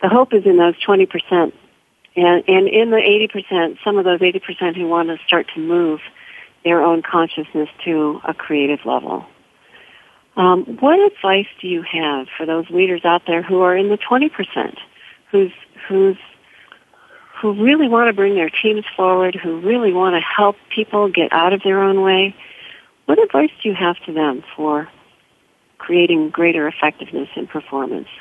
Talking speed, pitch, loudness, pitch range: 170 wpm, 185 Hz, -16 LUFS, 165-205 Hz